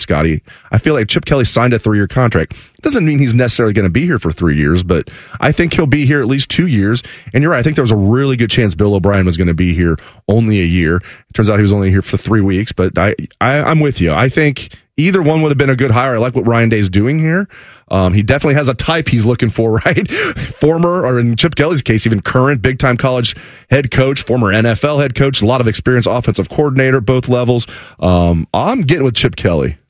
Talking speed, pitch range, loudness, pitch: 255 wpm, 100-135 Hz, -13 LUFS, 120 Hz